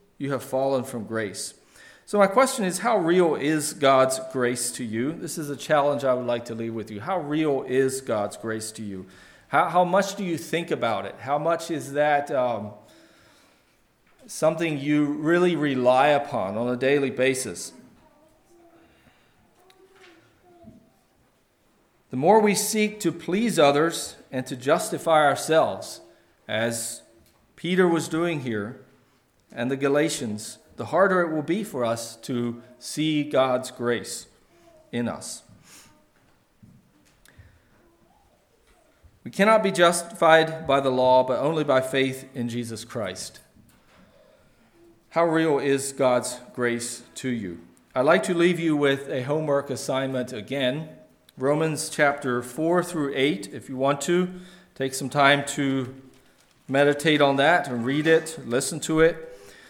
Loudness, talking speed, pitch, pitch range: -24 LUFS, 140 wpm, 140 Hz, 125-165 Hz